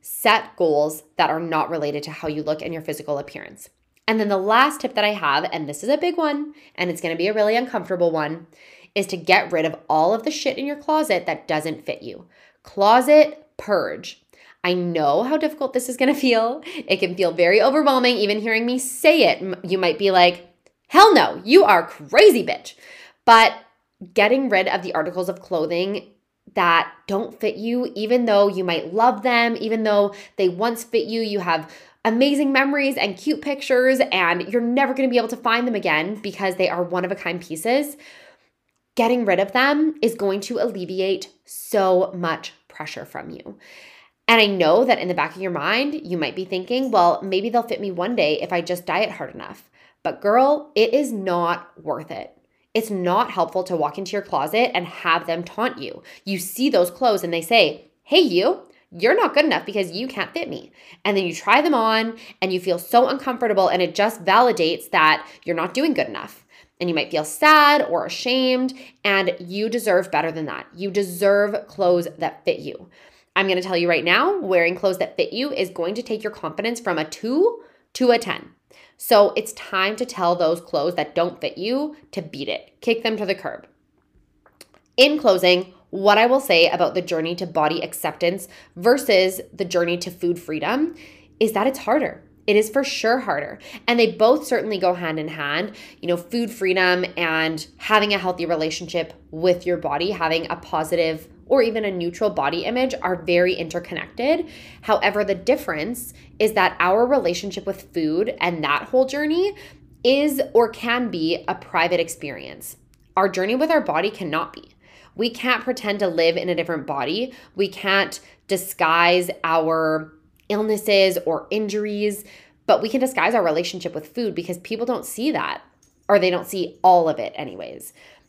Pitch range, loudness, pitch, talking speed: 175-245 Hz, -20 LUFS, 200 Hz, 195 wpm